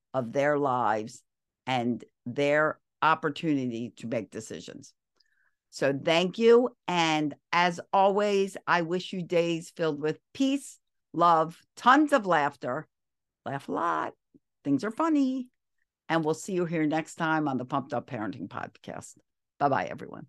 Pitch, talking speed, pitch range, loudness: 160 Hz, 140 wpm, 140-185 Hz, -27 LUFS